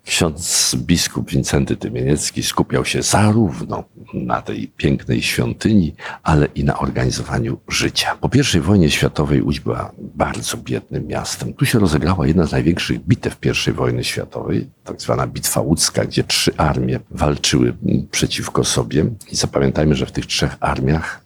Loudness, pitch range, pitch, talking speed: -18 LUFS, 65-90 Hz, 75 Hz, 145 wpm